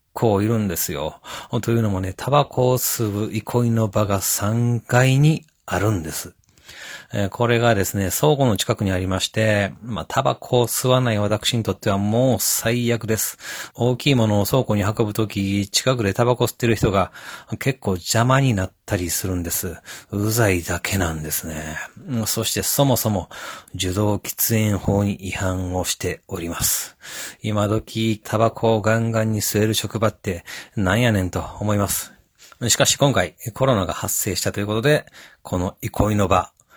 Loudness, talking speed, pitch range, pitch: -21 LUFS, 320 characters per minute, 95-120 Hz, 110 Hz